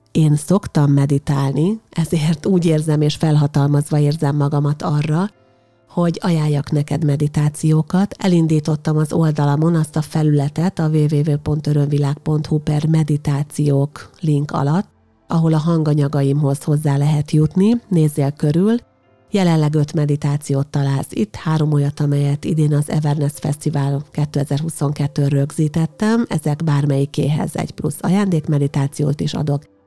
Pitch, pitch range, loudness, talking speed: 150 Hz, 145-160 Hz, -18 LUFS, 115 wpm